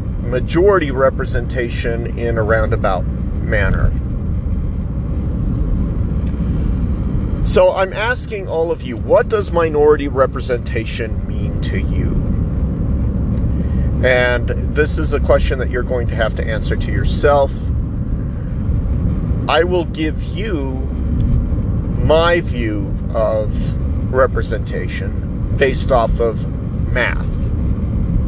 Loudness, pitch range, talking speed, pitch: -17 LUFS, 90-125 Hz, 95 wpm, 110 Hz